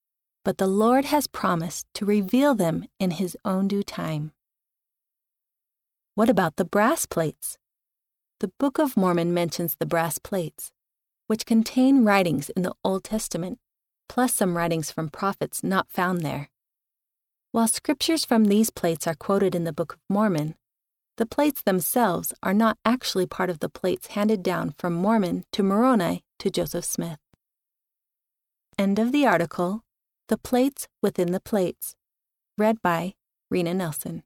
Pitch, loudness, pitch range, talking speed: 195 Hz, -24 LUFS, 170-225 Hz, 150 wpm